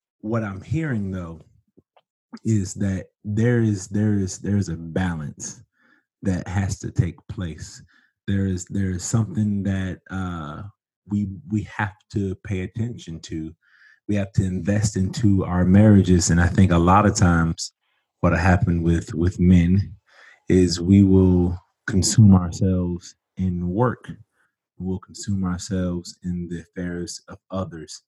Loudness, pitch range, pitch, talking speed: -22 LUFS, 90-105 Hz, 95 Hz, 145 wpm